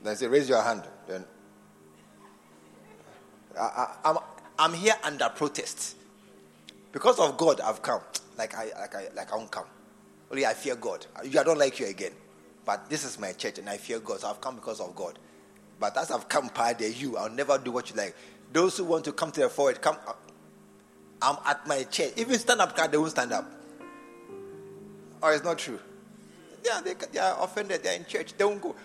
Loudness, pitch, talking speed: -29 LUFS, 155 Hz, 210 wpm